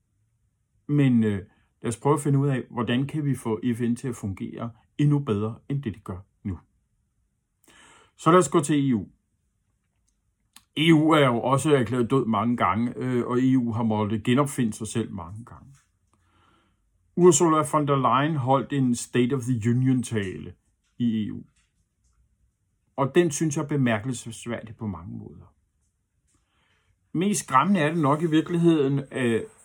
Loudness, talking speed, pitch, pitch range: -24 LUFS, 160 wpm, 120 Hz, 105-140 Hz